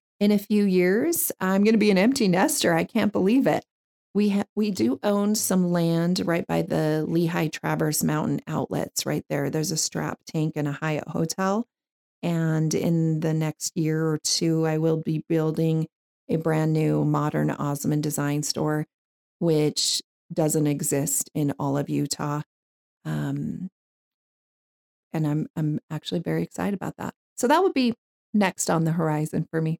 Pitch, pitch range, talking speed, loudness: 160 Hz, 150-190 Hz, 165 wpm, -24 LUFS